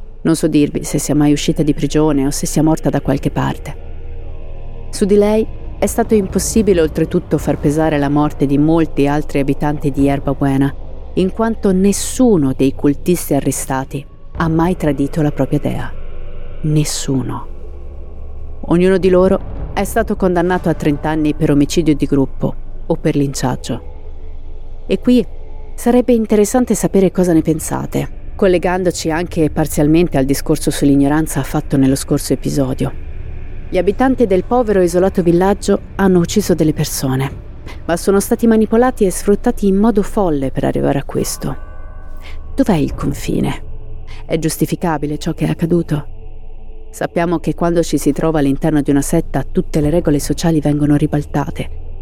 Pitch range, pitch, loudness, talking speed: 135-180 Hz, 150 Hz, -15 LUFS, 150 wpm